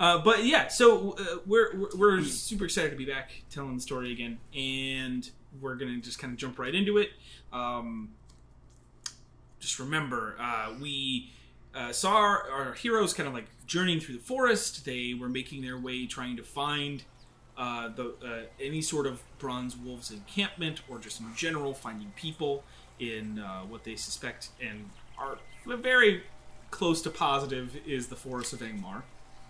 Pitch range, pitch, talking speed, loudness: 120-160 Hz, 130 Hz, 170 wpm, -30 LUFS